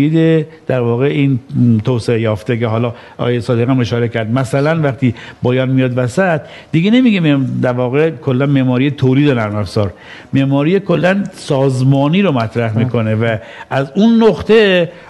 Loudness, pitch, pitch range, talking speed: -14 LUFS, 135 Hz, 120-155 Hz, 145 wpm